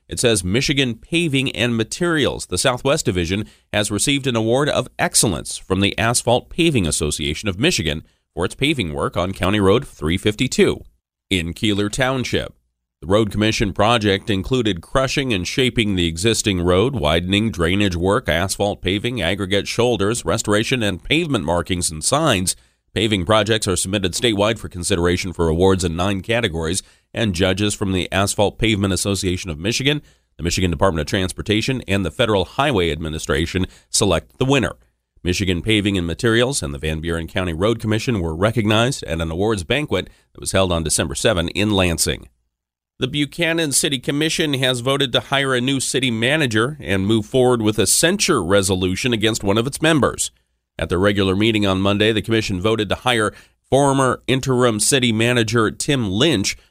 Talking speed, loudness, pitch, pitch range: 165 wpm, -19 LUFS, 105 Hz, 90-120 Hz